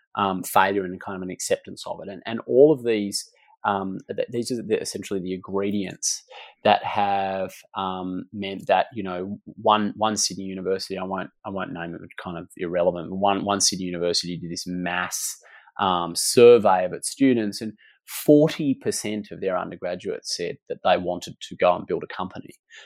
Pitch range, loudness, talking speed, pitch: 95-110 Hz, -24 LUFS, 185 wpm, 100 Hz